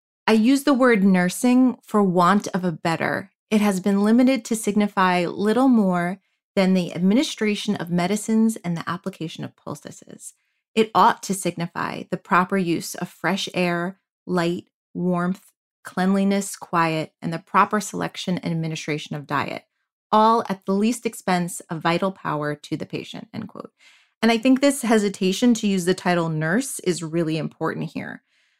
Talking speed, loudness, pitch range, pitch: 160 wpm, -22 LUFS, 175-220 Hz, 190 Hz